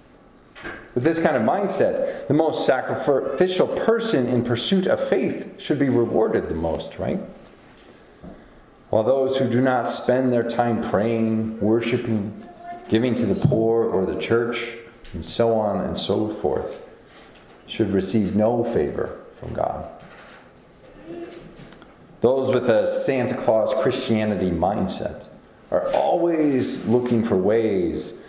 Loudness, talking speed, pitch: -22 LUFS, 125 wpm, 125 Hz